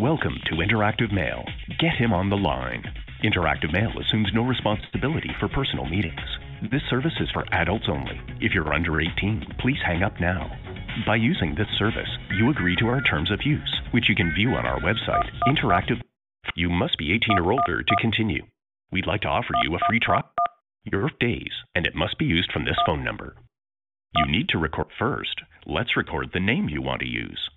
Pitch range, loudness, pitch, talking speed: 80-115 Hz, -24 LUFS, 105 Hz, 195 wpm